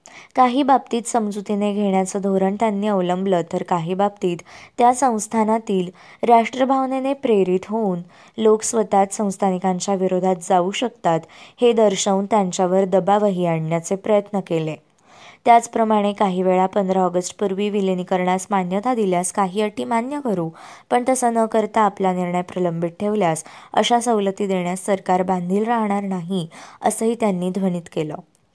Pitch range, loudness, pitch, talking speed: 185-220 Hz, -20 LUFS, 200 Hz, 125 wpm